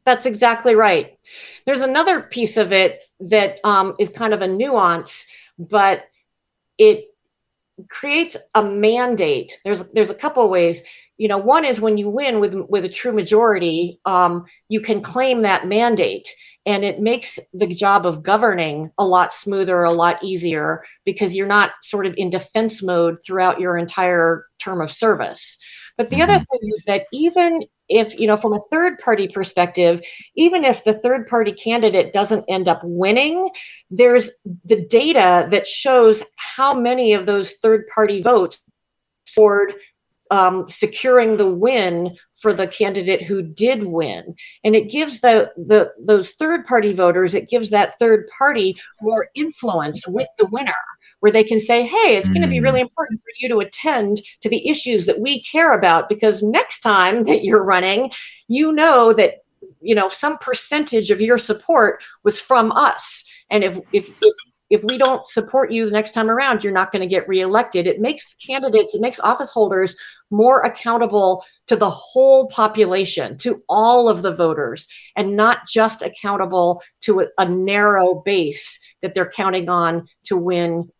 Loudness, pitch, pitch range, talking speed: -17 LUFS, 215 Hz, 190-245 Hz, 170 wpm